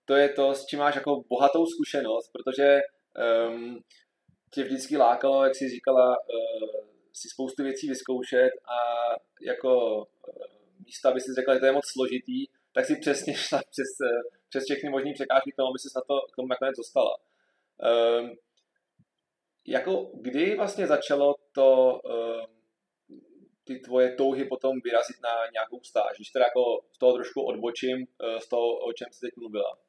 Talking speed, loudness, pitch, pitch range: 165 wpm, -27 LUFS, 135 Hz, 125-145 Hz